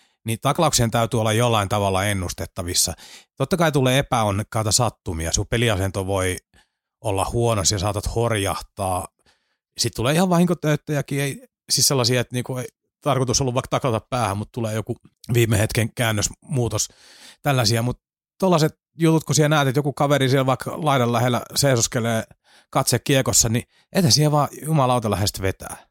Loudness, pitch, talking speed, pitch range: -21 LUFS, 120 Hz, 145 wpm, 110-140 Hz